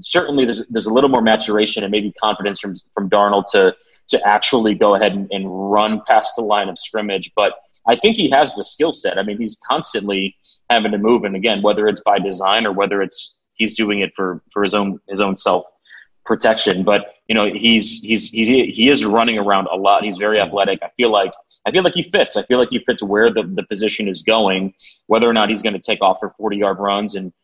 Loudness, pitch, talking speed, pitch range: -17 LUFS, 105 Hz, 235 wpm, 100-110 Hz